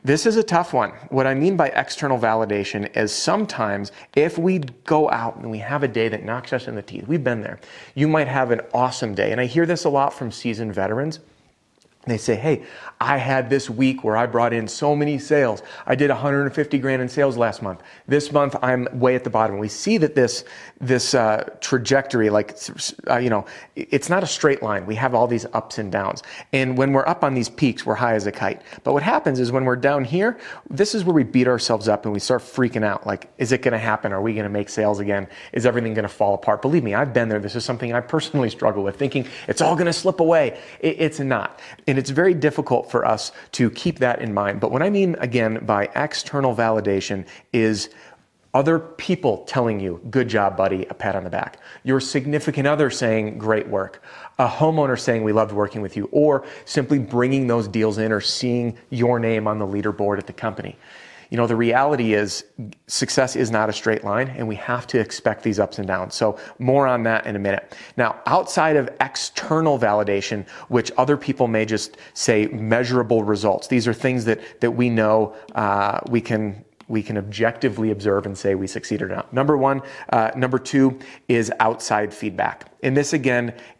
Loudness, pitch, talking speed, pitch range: -21 LUFS, 120 Hz, 220 wpm, 110-140 Hz